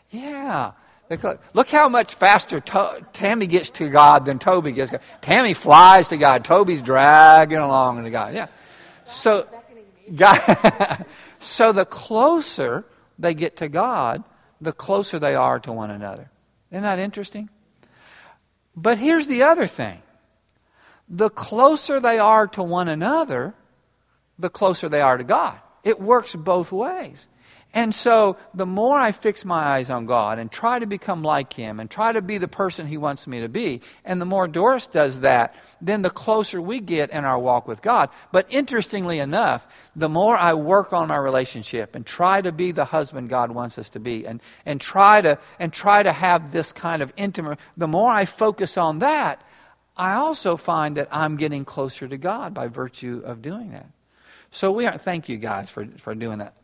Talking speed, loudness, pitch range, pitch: 180 wpm, -18 LUFS, 140-210 Hz, 175 Hz